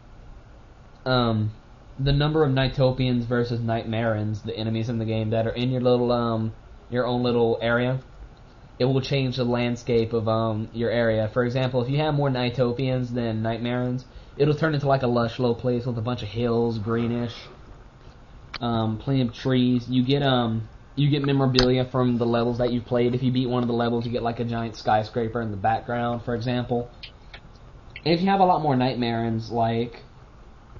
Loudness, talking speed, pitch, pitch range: -24 LUFS, 190 wpm, 120 Hz, 115-125 Hz